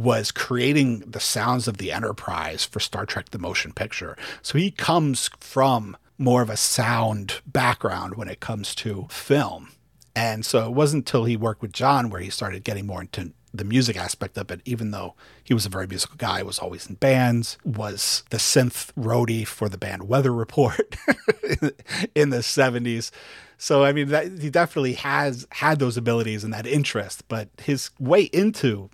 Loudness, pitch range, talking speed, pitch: -23 LUFS, 105-140 Hz, 185 wpm, 120 Hz